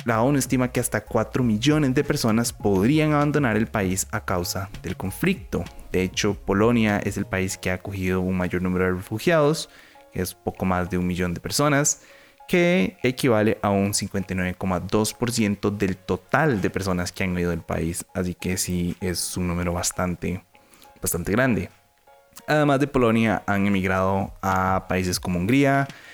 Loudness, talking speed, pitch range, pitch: -23 LUFS, 165 wpm, 90-130 Hz, 100 Hz